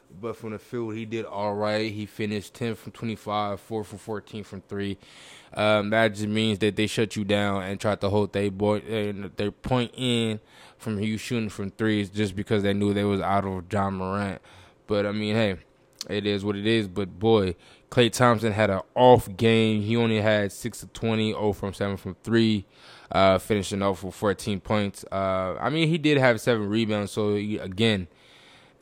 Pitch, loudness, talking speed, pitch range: 105 Hz, -25 LUFS, 200 wpm, 100-110 Hz